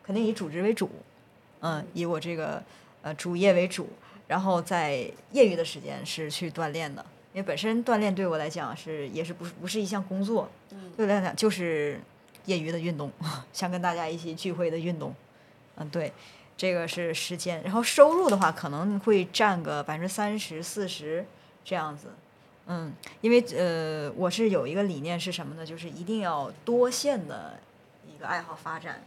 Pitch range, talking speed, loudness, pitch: 160-200 Hz, 270 characters per minute, -28 LUFS, 175 Hz